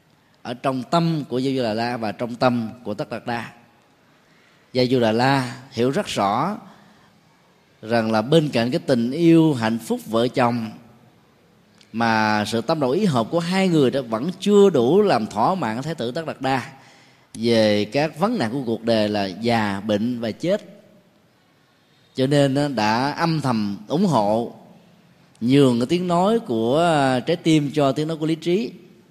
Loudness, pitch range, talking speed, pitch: -21 LUFS, 115-170 Hz, 175 wpm, 135 Hz